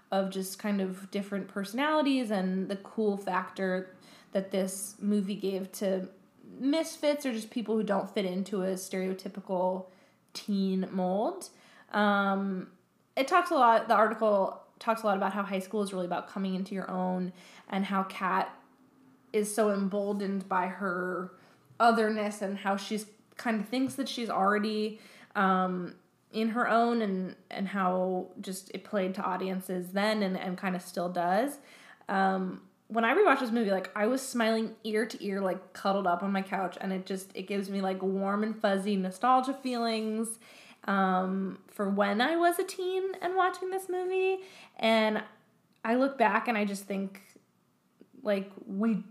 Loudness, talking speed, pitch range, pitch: -30 LUFS, 165 wpm, 190-225 Hz, 200 Hz